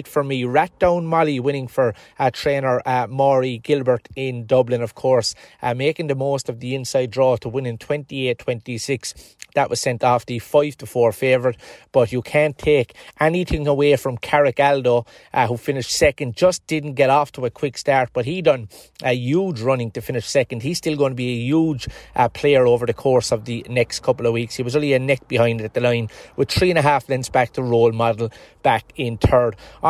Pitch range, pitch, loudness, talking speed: 120-145 Hz, 130 Hz, -20 LUFS, 215 wpm